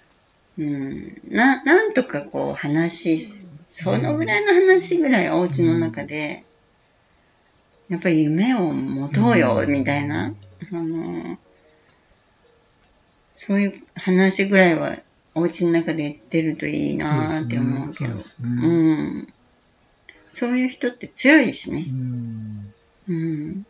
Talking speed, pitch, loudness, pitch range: 215 characters per minute, 165 Hz, -21 LUFS, 145-195 Hz